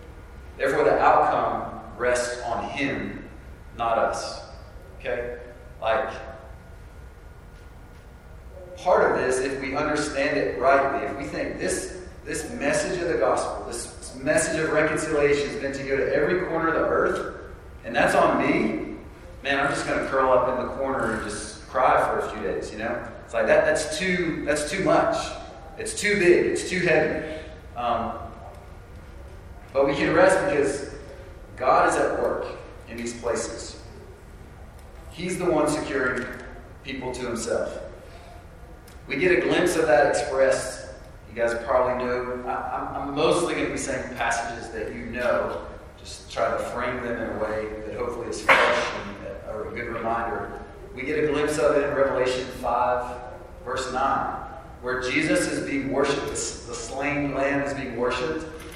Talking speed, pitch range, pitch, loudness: 160 wpm, 105-145 Hz, 125 Hz, -24 LUFS